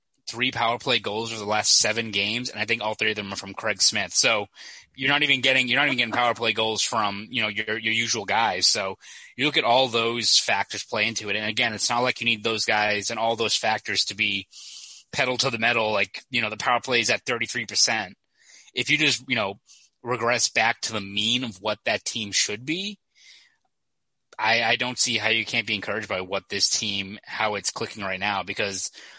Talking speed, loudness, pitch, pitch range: 230 wpm, -23 LUFS, 115 Hz, 105-125 Hz